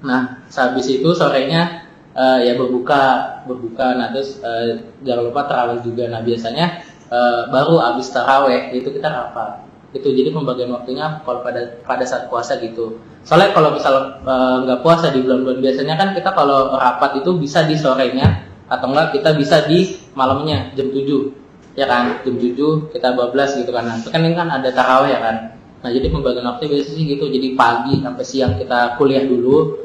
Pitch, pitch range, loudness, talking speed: 130 Hz, 125-145 Hz, -16 LUFS, 180 wpm